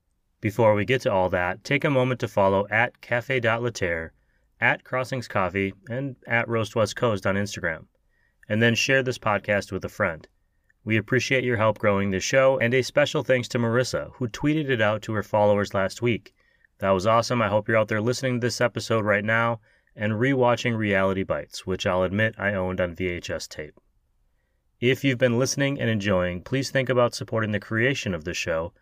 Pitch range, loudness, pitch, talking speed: 100-125 Hz, -24 LUFS, 115 Hz, 200 wpm